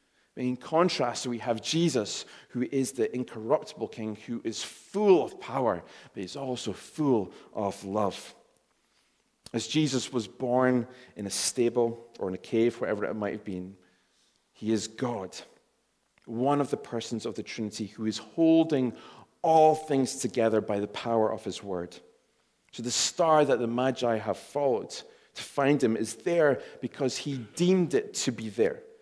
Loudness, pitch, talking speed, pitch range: -29 LUFS, 120 Hz, 165 wpm, 110-135 Hz